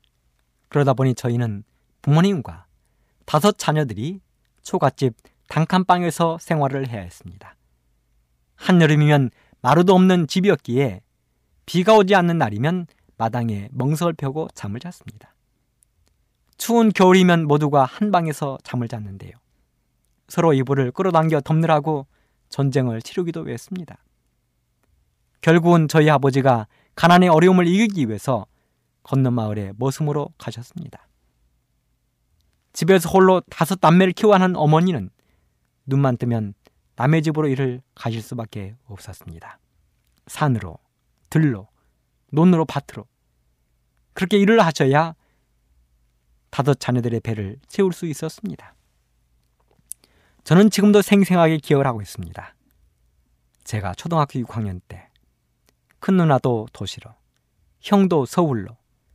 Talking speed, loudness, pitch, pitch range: 270 characters per minute, -19 LUFS, 135 Hz, 100-165 Hz